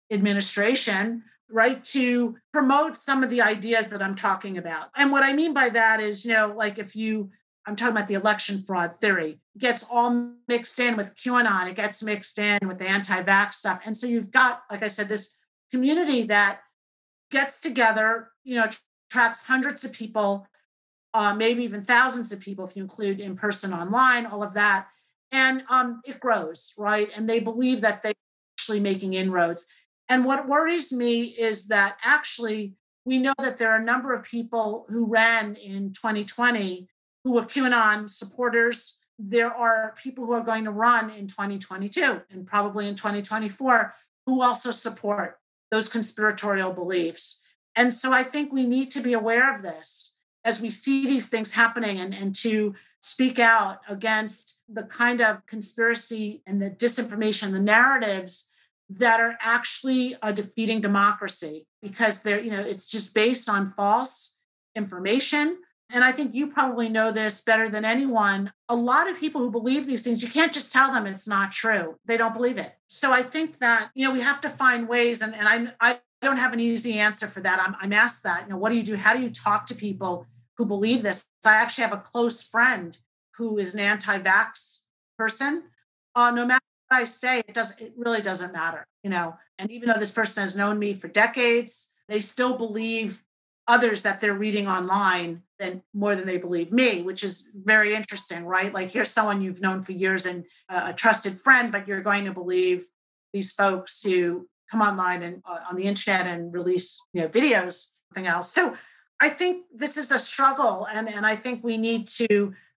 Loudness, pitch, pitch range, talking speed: -24 LUFS, 220 Hz, 200-240 Hz, 190 wpm